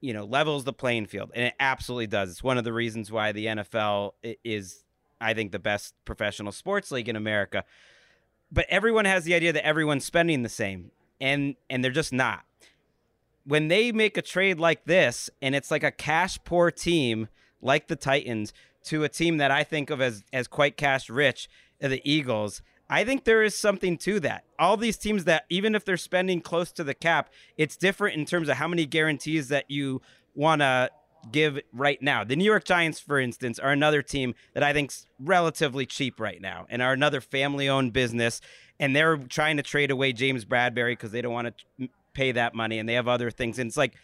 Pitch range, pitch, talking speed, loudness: 120-160 Hz, 135 Hz, 210 wpm, -26 LUFS